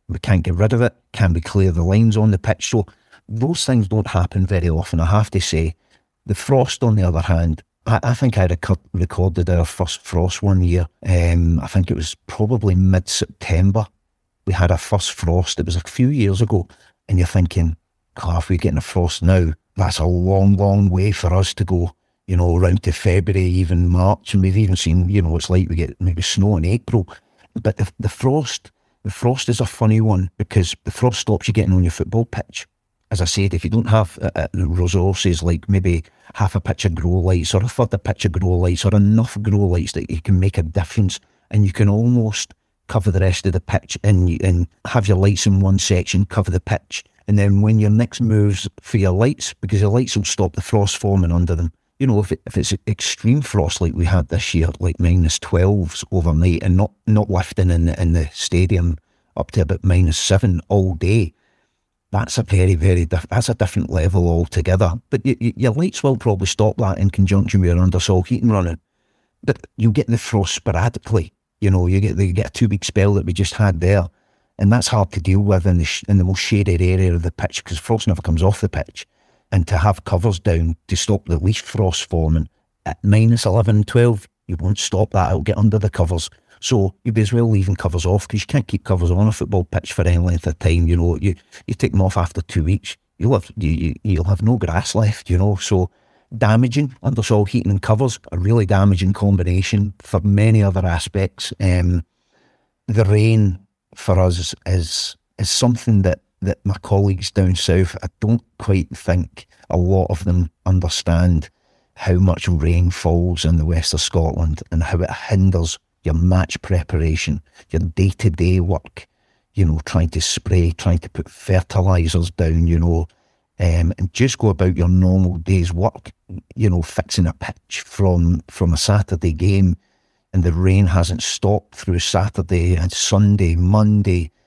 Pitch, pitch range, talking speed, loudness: 95 Hz, 90-105 Hz, 210 wpm, -18 LUFS